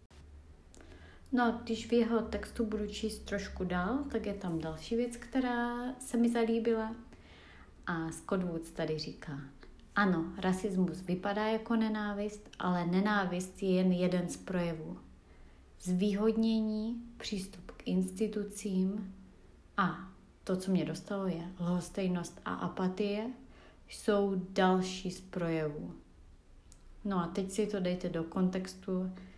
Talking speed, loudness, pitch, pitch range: 125 wpm, -34 LUFS, 185 Hz, 170-215 Hz